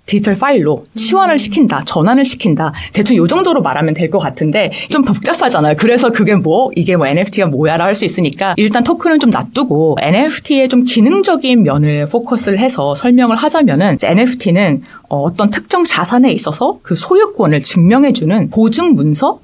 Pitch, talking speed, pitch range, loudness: 215 Hz, 375 characters per minute, 175-255 Hz, -11 LUFS